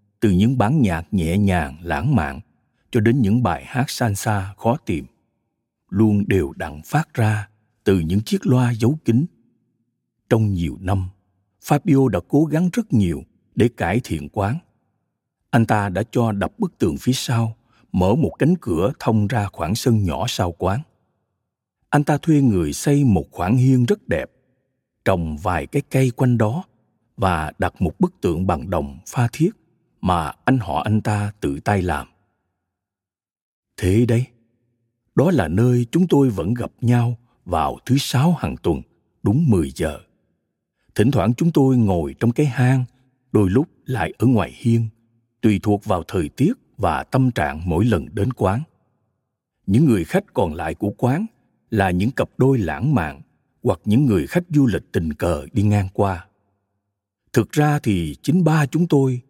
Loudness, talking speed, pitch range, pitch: -20 LUFS, 170 wpm, 100-130 Hz, 115 Hz